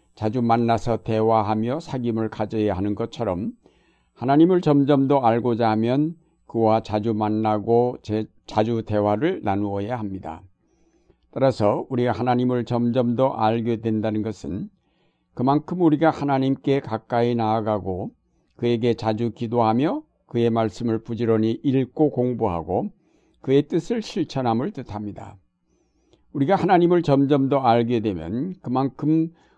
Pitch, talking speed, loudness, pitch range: 120 Hz, 290 characters per minute, -22 LUFS, 110-135 Hz